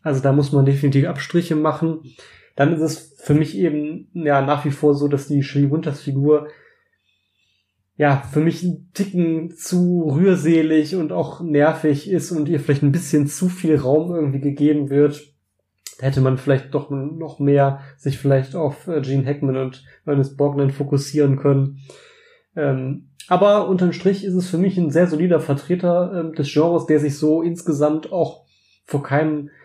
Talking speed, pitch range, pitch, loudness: 160 wpm, 140-165 Hz, 150 Hz, -19 LUFS